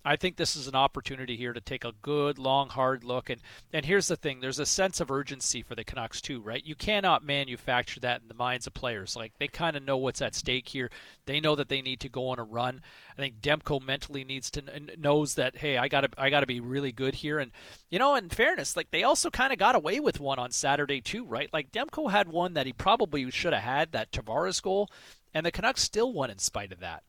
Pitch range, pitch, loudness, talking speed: 125-150 Hz, 135 Hz, -29 LUFS, 255 wpm